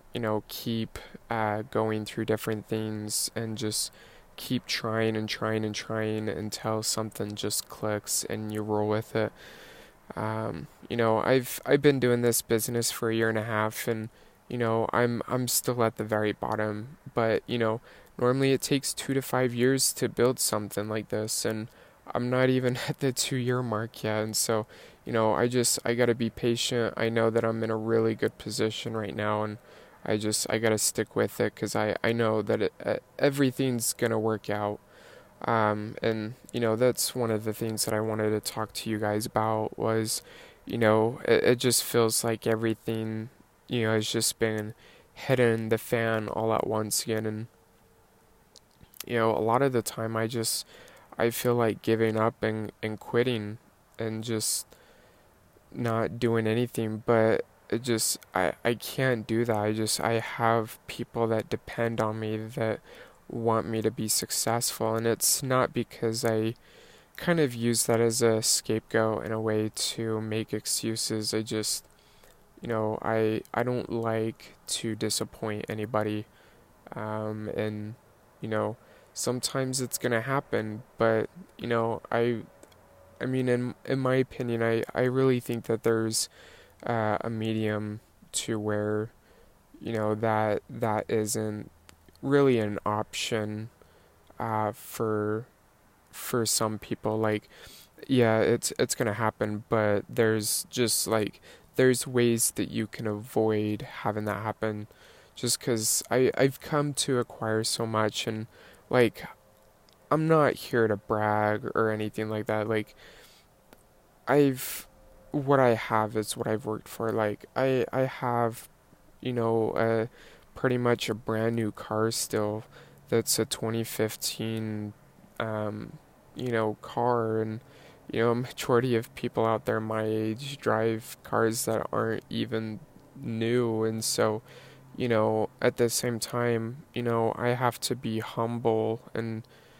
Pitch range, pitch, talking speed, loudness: 110-120 Hz, 110 Hz, 160 wpm, -28 LUFS